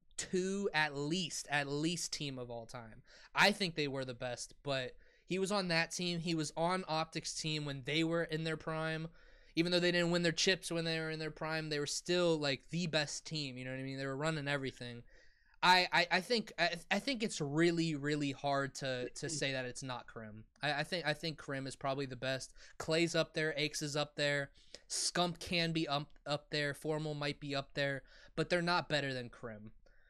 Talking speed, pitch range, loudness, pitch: 225 wpm, 140-170 Hz, -36 LUFS, 155 Hz